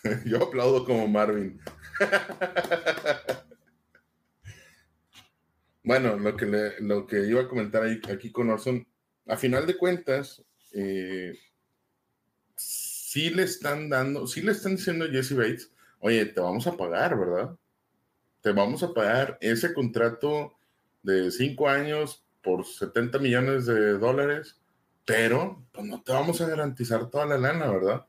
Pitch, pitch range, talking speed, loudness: 125 Hz, 105-145 Hz, 135 wpm, -27 LUFS